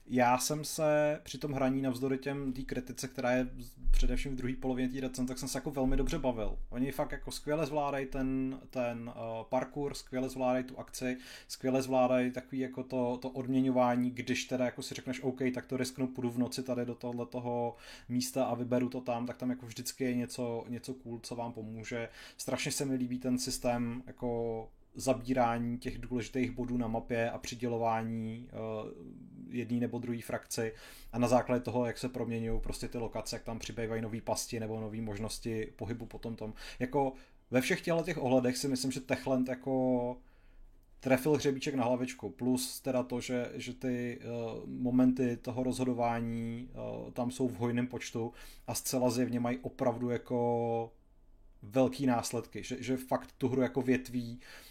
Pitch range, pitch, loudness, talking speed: 120-130 Hz, 125 Hz, -35 LUFS, 180 wpm